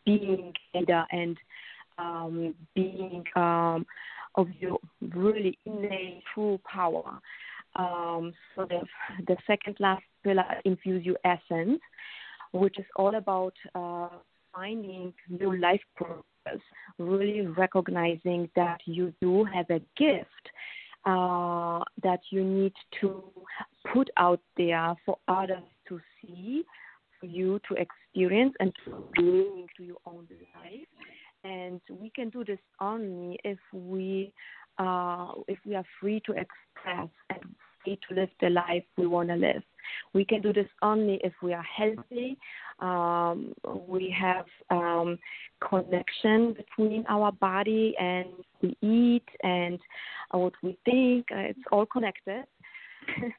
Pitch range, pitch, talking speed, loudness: 180-210 Hz, 190 Hz, 125 wpm, -29 LUFS